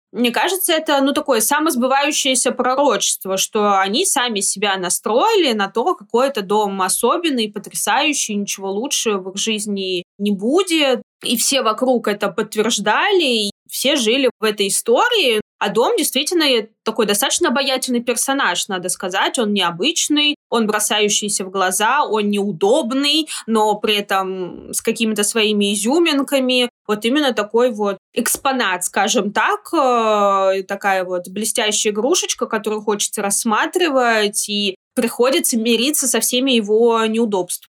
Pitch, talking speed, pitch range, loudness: 225 Hz, 130 wpm, 205-270 Hz, -17 LUFS